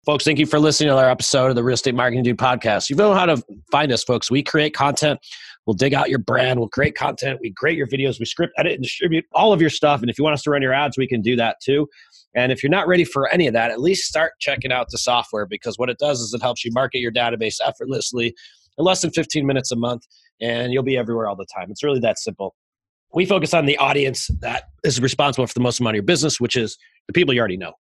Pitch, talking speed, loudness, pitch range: 130 Hz, 280 wpm, -19 LUFS, 120-150 Hz